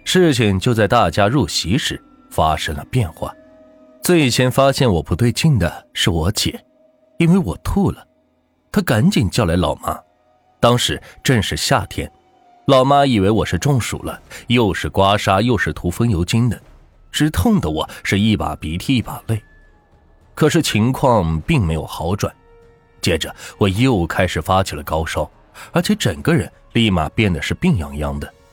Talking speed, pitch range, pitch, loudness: 230 characters per minute, 90-140 Hz, 115 Hz, -17 LUFS